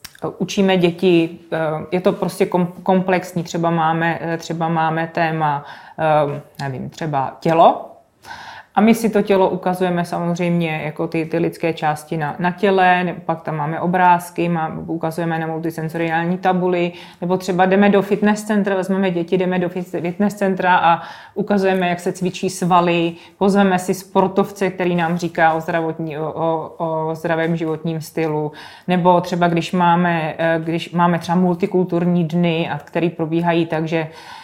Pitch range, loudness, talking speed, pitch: 165-185 Hz, -18 LUFS, 145 wpm, 170 Hz